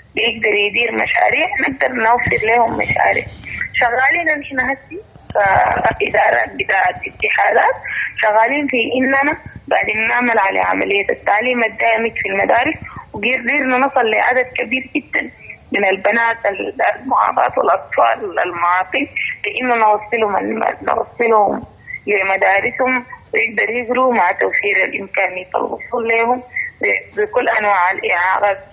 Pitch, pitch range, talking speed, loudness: 245 Hz, 215-275 Hz, 100 wpm, -15 LUFS